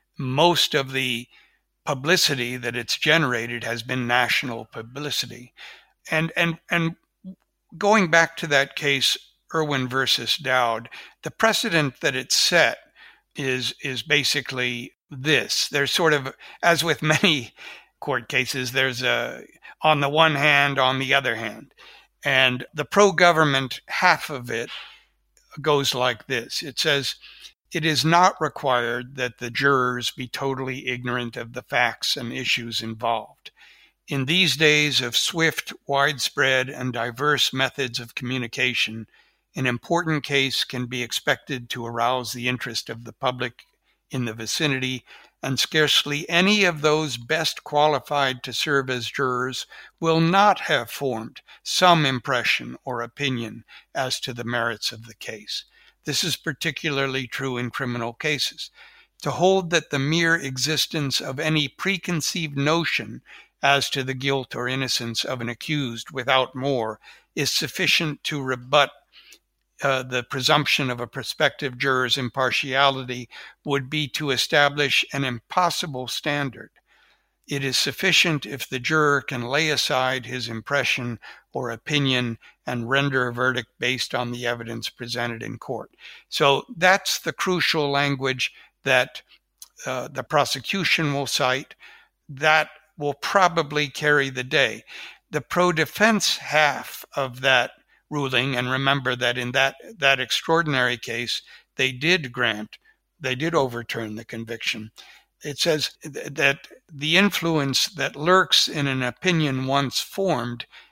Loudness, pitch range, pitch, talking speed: -22 LUFS, 125-155 Hz, 135 Hz, 135 wpm